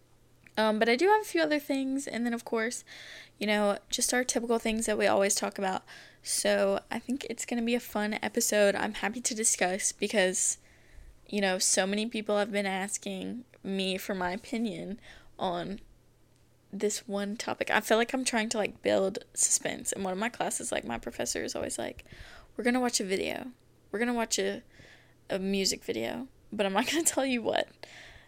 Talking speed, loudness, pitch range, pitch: 195 wpm, -30 LUFS, 195-240 Hz, 210 Hz